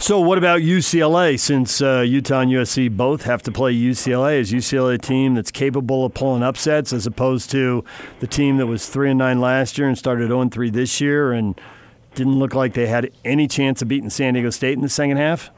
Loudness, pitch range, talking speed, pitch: -18 LUFS, 125-140 Hz, 225 wpm, 130 Hz